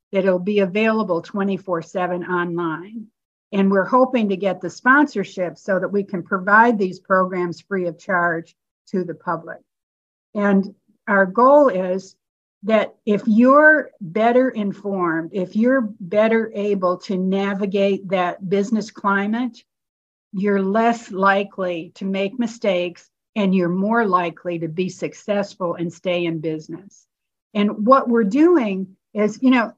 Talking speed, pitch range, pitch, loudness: 135 wpm, 180-215 Hz, 195 Hz, -19 LUFS